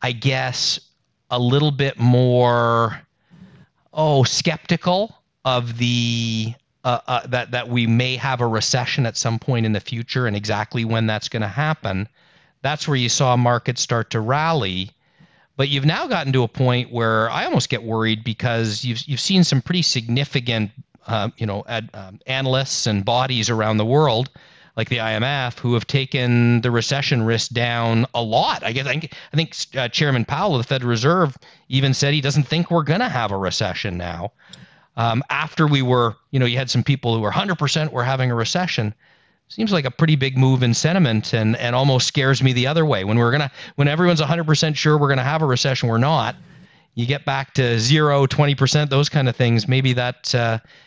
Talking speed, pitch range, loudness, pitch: 200 wpm, 115-145 Hz, -19 LUFS, 130 Hz